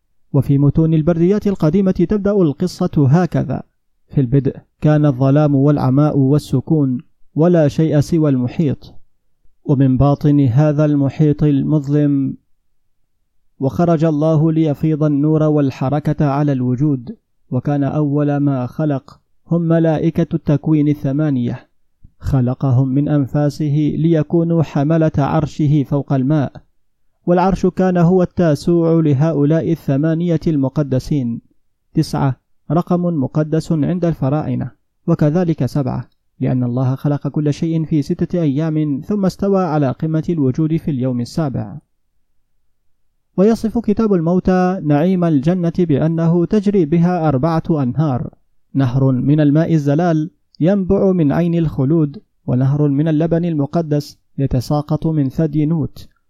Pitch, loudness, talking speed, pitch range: 150 Hz, -16 LUFS, 110 wpm, 140-165 Hz